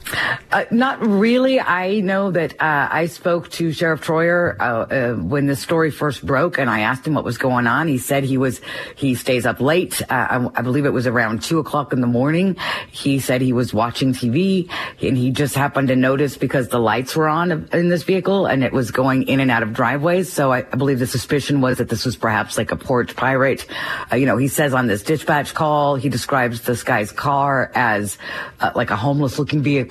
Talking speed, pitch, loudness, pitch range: 225 wpm, 140 Hz, -18 LUFS, 125-160 Hz